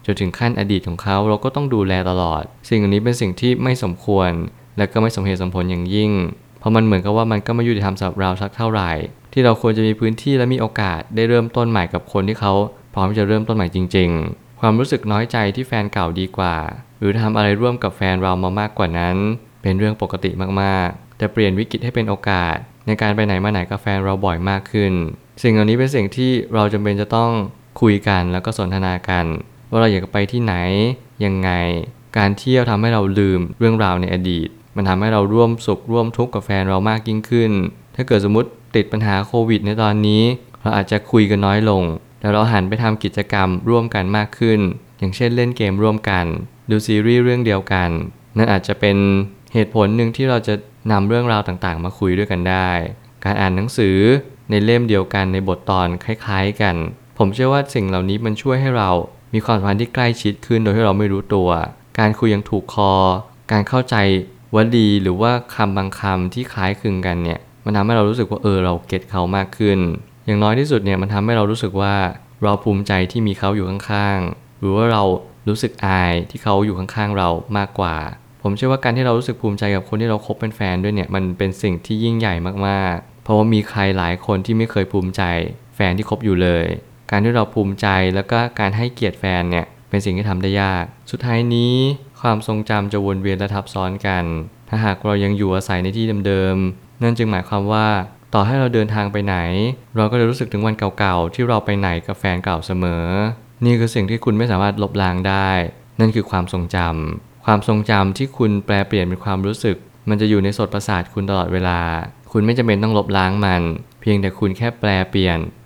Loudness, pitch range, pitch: -18 LUFS, 95-115 Hz, 105 Hz